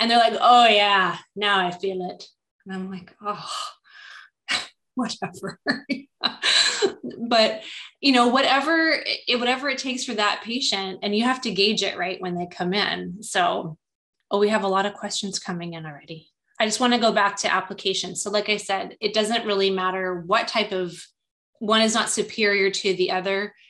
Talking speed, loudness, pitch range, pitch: 185 wpm, -22 LUFS, 190-235 Hz, 205 Hz